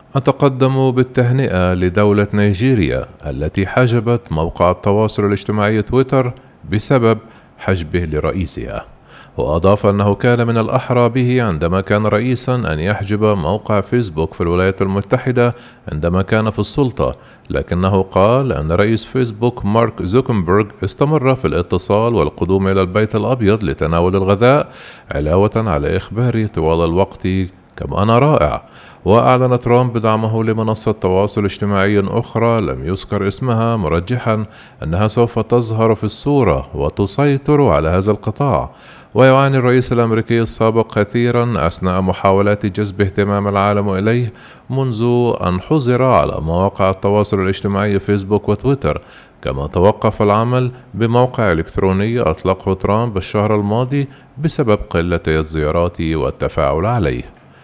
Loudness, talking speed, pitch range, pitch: -15 LUFS, 115 wpm, 95-120 Hz, 105 Hz